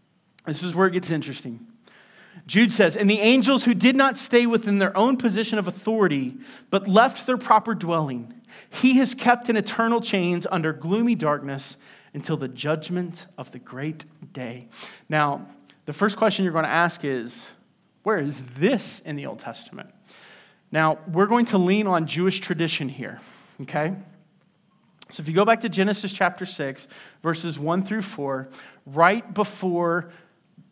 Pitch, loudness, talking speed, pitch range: 185 Hz, -22 LUFS, 160 wpm, 155-215 Hz